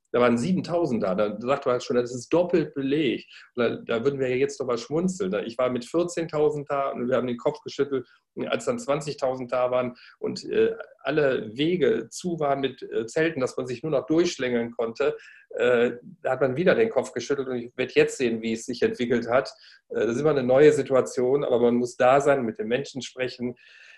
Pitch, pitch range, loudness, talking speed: 140 Hz, 125-165 Hz, -25 LUFS, 205 wpm